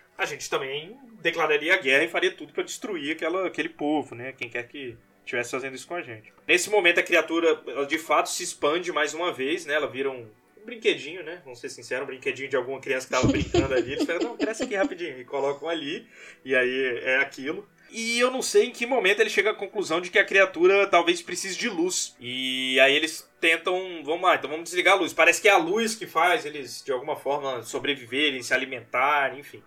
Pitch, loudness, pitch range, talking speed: 175 Hz, -24 LUFS, 140-220 Hz, 225 wpm